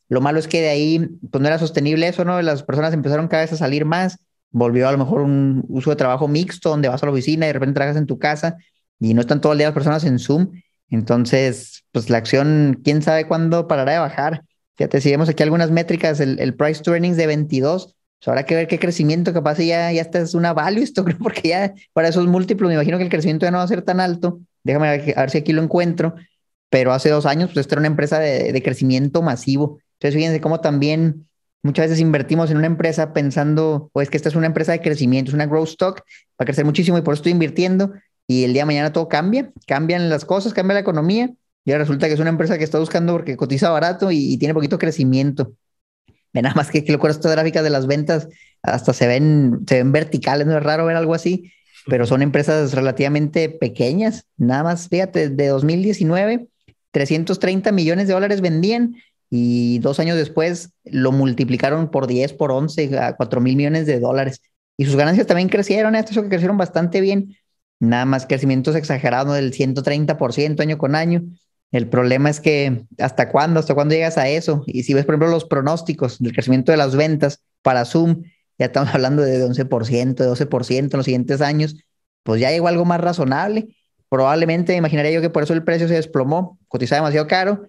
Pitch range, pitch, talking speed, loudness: 140-170 Hz, 155 Hz, 220 wpm, -18 LUFS